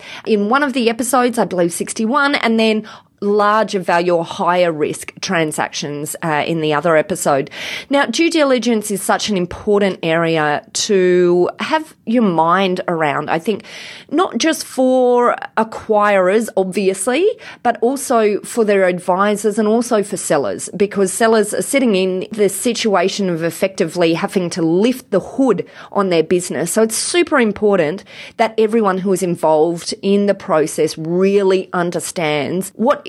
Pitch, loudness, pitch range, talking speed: 200 Hz, -16 LUFS, 175-225 Hz, 150 wpm